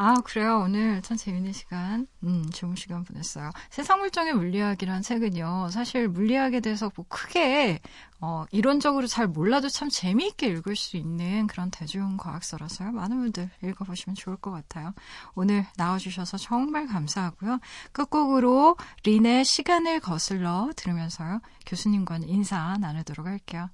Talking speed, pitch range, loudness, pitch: 350 characters per minute, 180-240 Hz, -27 LUFS, 200 Hz